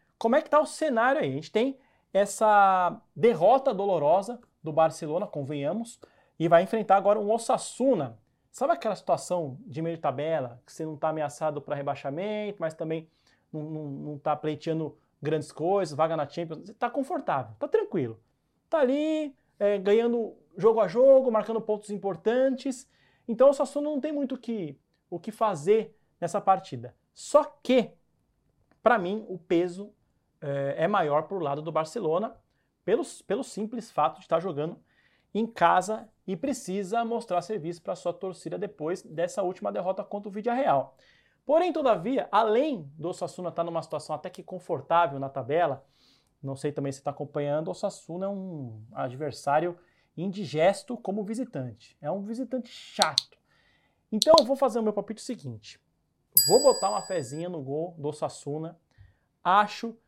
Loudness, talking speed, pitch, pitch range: -27 LUFS, 160 wpm, 190 Hz, 155-225 Hz